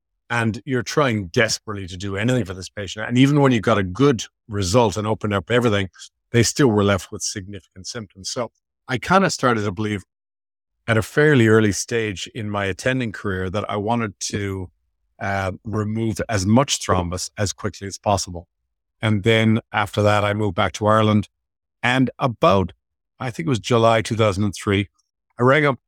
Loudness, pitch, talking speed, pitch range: -20 LUFS, 105 Hz, 180 wpm, 95-115 Hz